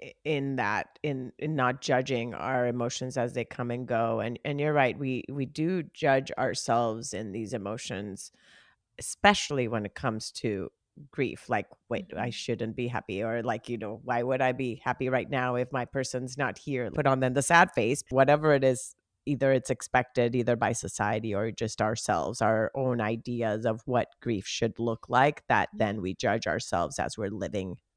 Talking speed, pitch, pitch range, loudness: 190 wpm, 125 Hz, 115-130 Hz, -29 LUFS